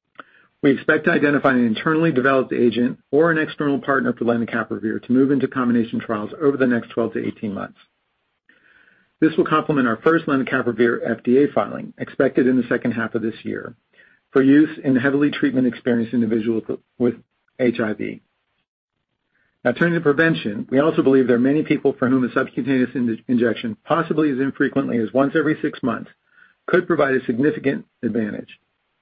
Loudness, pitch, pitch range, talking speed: -20 LUFS, 130 Hz, 120-145 Hz, 165 wpm